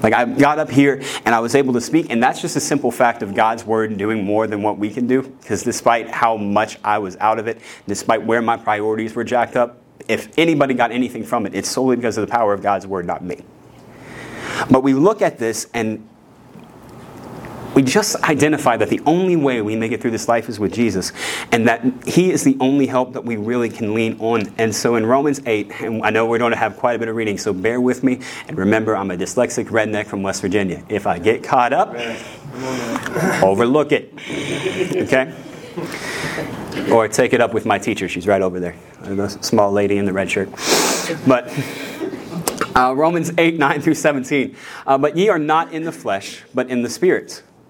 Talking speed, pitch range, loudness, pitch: 215 wpm, 110-135 Hz, -18 LUFS, 120 Hz